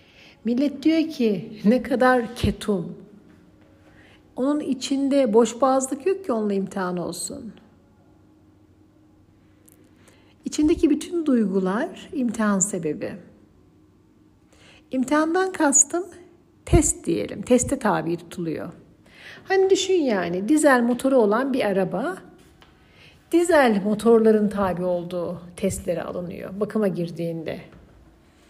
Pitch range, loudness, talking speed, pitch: 175-275 Hz, -22 LUFS, 90 wpm, 215 Hz